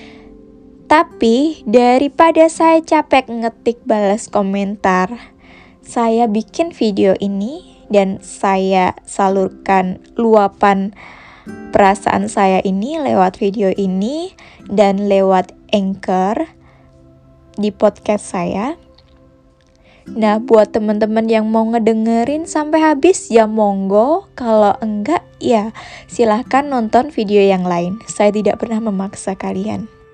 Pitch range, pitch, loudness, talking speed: 195-235 Hz, 210 Hz, -15 LUFS, 100 wpm